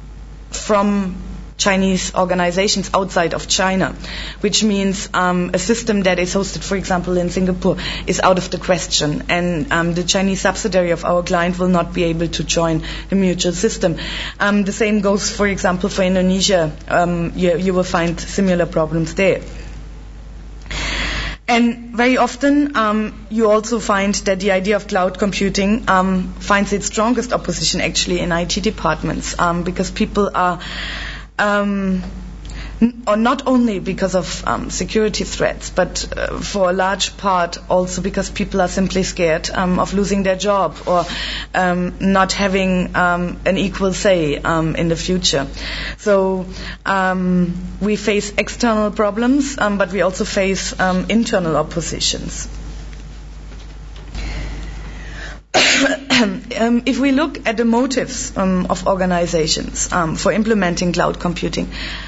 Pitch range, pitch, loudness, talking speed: 180-205 Hz, 190 Hz, -17 LUFS, 145 wpm